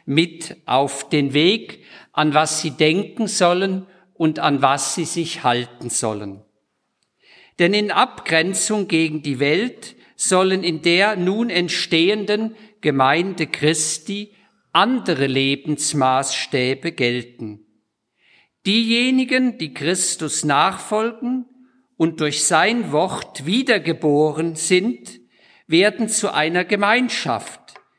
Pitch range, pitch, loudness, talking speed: 150-205 Hz, 170 Hz, -19 LUFS, 100 wpm